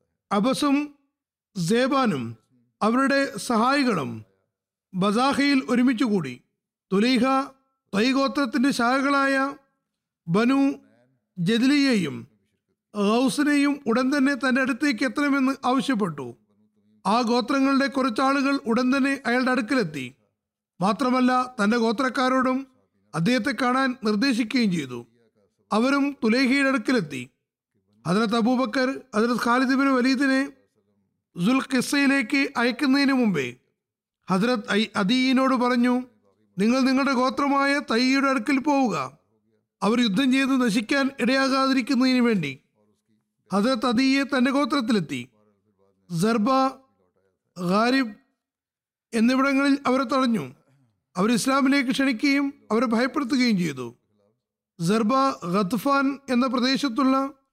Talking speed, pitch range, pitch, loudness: 80 wpm, 195-270 Hz, 250 Hz, -22 LUFS